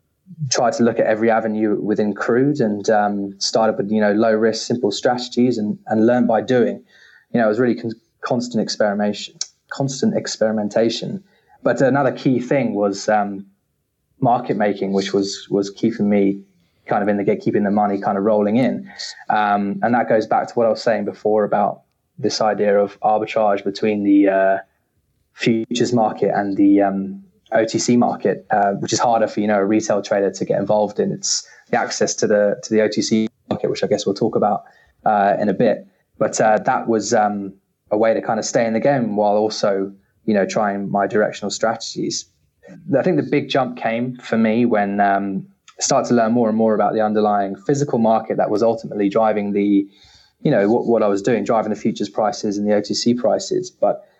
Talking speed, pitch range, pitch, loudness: 200 wpm, 100-115 Hz, 105 Hz, -19 LUFS